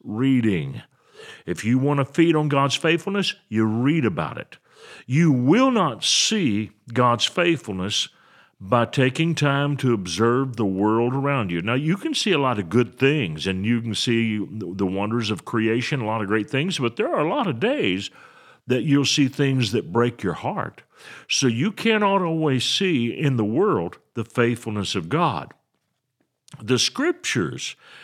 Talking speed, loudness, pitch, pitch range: 170 wpm, -22 LUFS, 125 Hz, 110-150 Hz